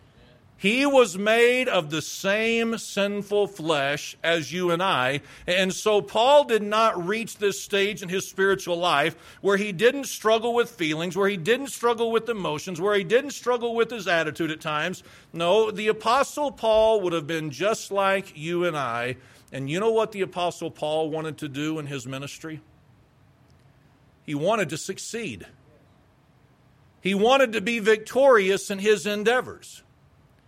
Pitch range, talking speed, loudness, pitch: 155-220 Hz, 160 wpm, -24 LUFS, 195 Hz